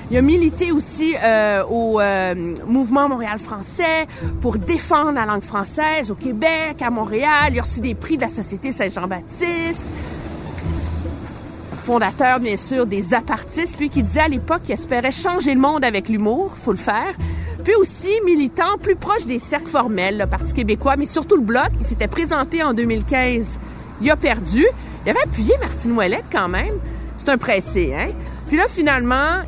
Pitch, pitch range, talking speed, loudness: 260 Hz, 215-315 Hz, 175 wpm, -19 LUFS